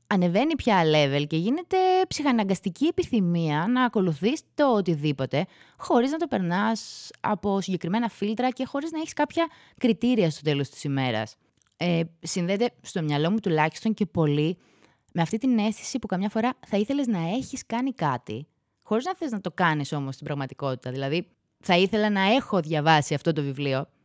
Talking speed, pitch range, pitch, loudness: 165 wpm, 150-240 Hz, 190 Hz, -25 LUFS